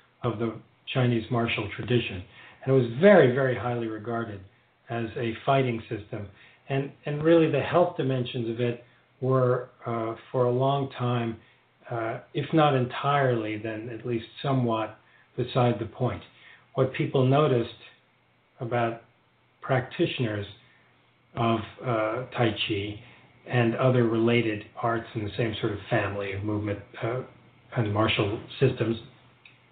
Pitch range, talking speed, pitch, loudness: 115-130 Hz, 135 wpm, 120 Hz, -27 LUFS